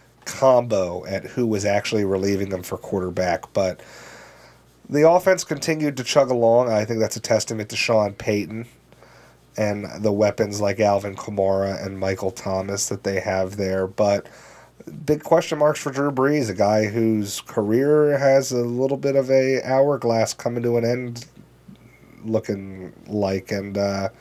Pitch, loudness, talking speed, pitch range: 110 Hz, -21 LUFS, 155 wpm, 100-130 Hz